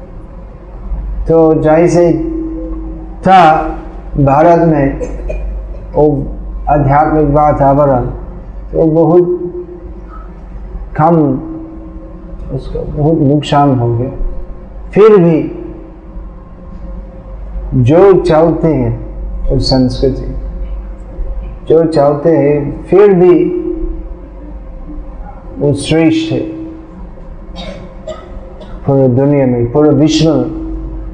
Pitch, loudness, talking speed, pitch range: 155 Hz, -10 LUFS, 65 wpm, 135-165 Hz